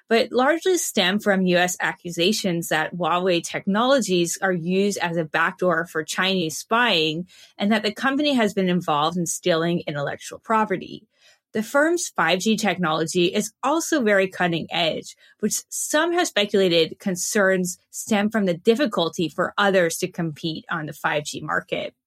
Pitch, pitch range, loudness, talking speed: 185 Hz, 170-220 Hz, -22 LUFS, 145 wpm